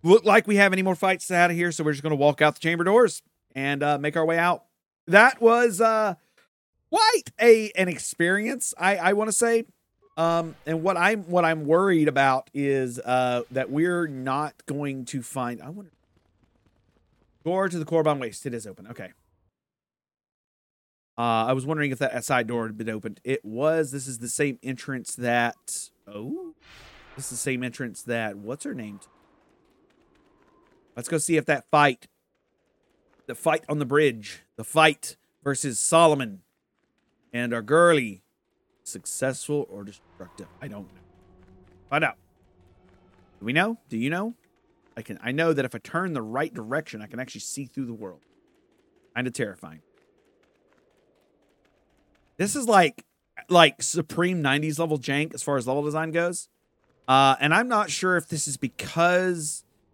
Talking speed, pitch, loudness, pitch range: 170 wpm, 150 Hz, -24 LUFS, 120-180 Hz